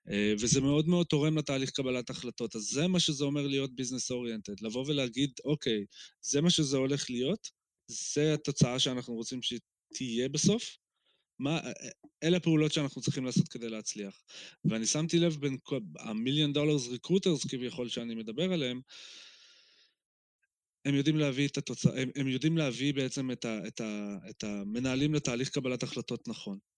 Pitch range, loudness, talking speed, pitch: 120-150 Hz, -32 LUFS, 145 wpm, 135 Hz